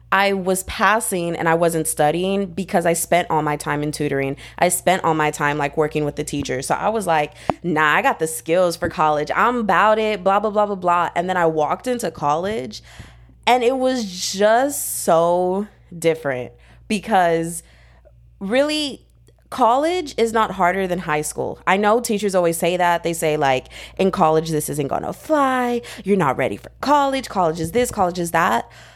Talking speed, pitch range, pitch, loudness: 190 wpm, 155-210 Hz, 175 Hz, -19 LUFS